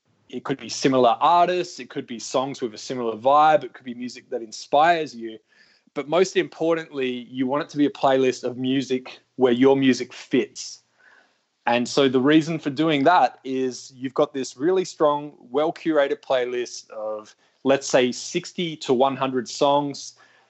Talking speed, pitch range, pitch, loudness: 175 wpm, 125-155 Hz, 135 Hz, -22 LUFS